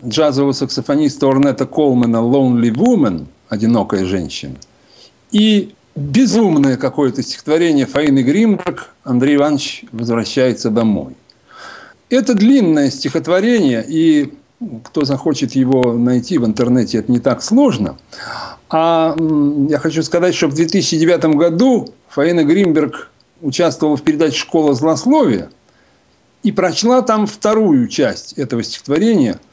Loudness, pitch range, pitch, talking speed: -14 LUFS, 130-205 Hz, 150 Hz, 110 wpm